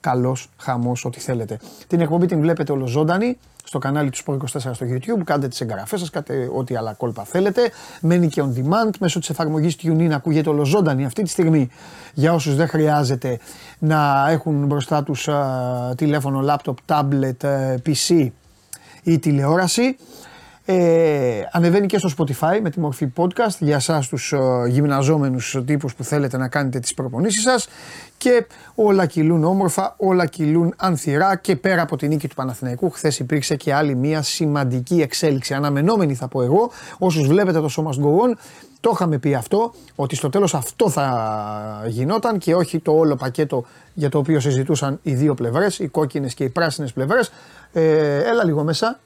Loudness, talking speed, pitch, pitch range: -19 LUFS, 165 wpm, 150 Hz, 135-170 Hz